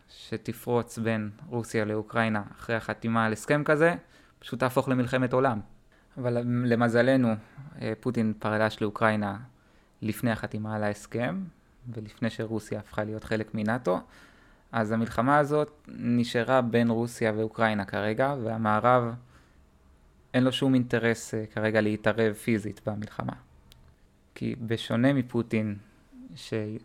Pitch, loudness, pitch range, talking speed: 115 Hz, -28 LUFS, 105-120 Hz, 110 wpm